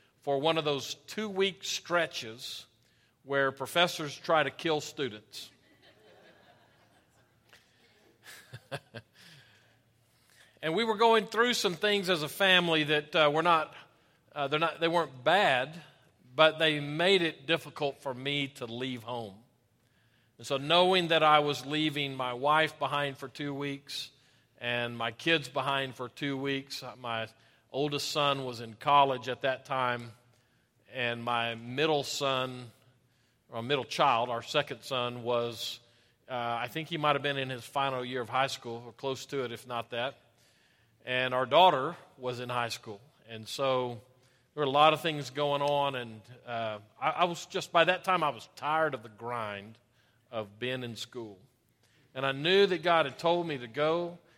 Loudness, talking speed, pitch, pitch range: -30 LUFS, 165 wpm, 135 Hz, 120-155 Hz